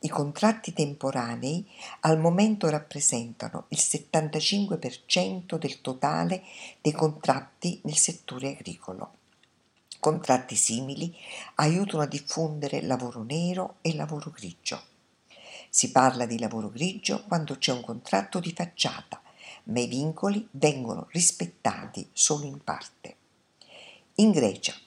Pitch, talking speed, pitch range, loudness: 155 Hz, 110 wpm, 130-175 Hz, -27 LUFS